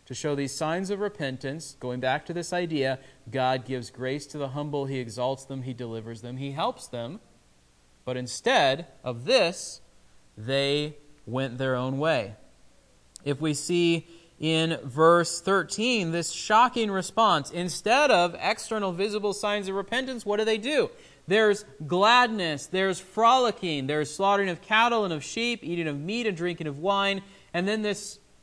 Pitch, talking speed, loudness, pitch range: 160 Hz, 160 wpm, -26 LUFS, 135-200 Hz